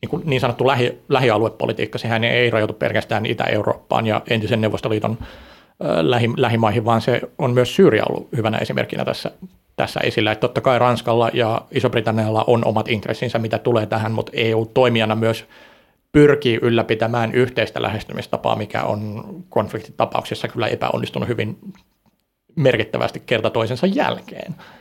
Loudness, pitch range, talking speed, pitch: -19 LUFS, 110-125 Hz, 130 wpm, 115 Hz